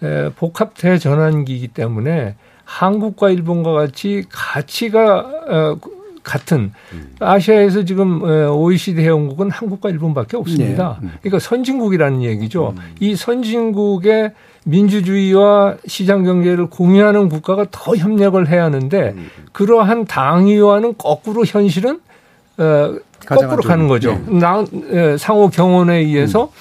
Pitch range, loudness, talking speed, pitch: 155-205 Hz, -14 LUFS, 280 characters per minute, 180 Hz